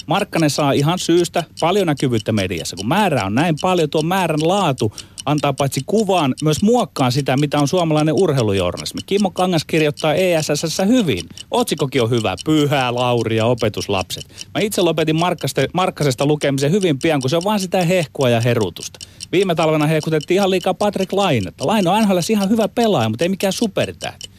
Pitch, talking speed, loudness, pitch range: 155 Hz, 165 wpm, -17 LUFS, 135-185 Hz